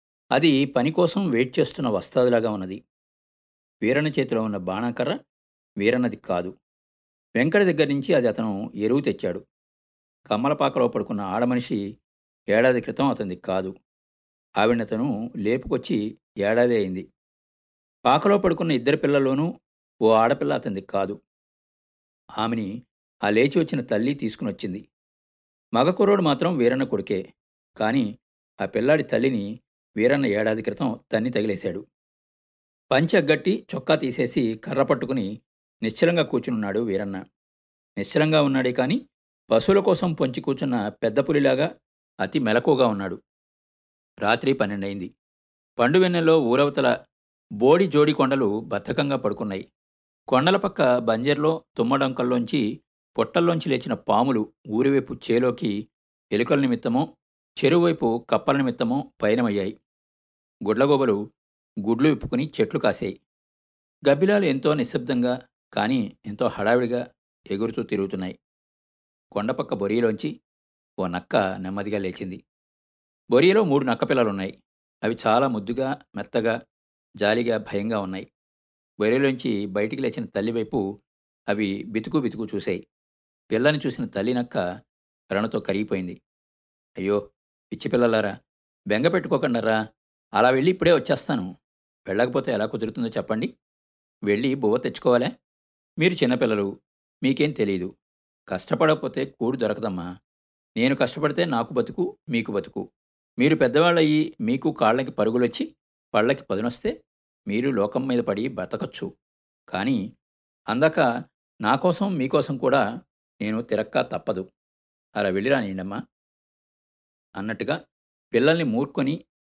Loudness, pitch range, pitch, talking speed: -23 LUFS, 95-140 Hz, 115 Hz, 100 wpm